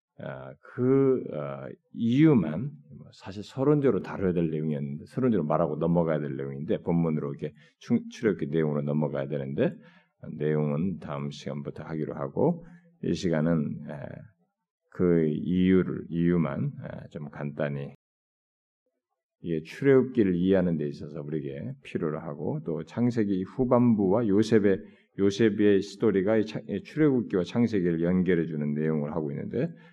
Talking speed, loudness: 295 characters per minute, -27 LUFS